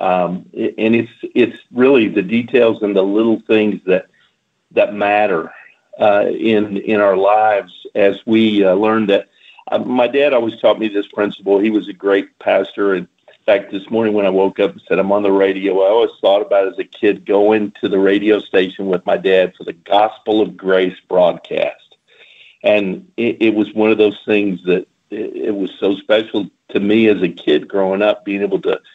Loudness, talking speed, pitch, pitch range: -15 LUFS, 200 wpm, 105 Hz, 95-110 Hz